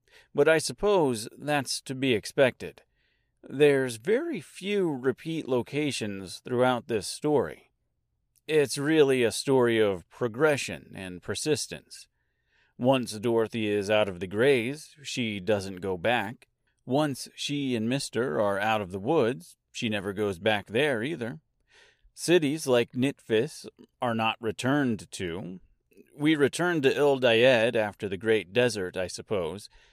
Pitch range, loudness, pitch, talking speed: 110-145 Hz, -27 LUFS, 125 Hz, 130 wpm